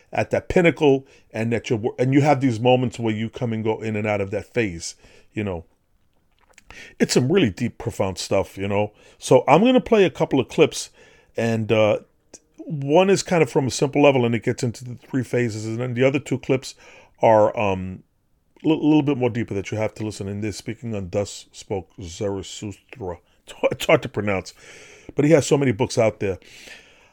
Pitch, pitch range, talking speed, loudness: 120 Hz, 105-145 Hz, 210 wpm, -21 LUFS